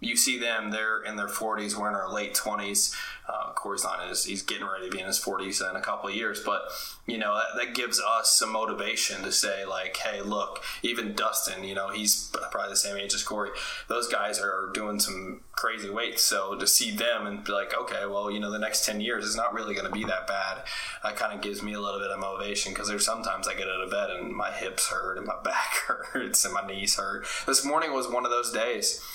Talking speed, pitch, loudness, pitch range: 250 wpm, 105 Hz, -28 LUFS, 100-110 Hz